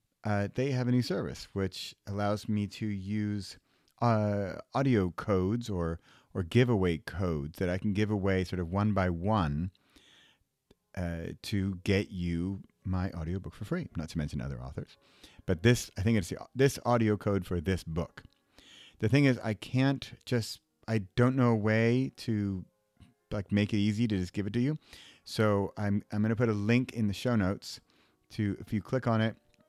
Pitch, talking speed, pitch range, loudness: 105 Hz, 190 wpm, 95-115 Hz, -31 LUFS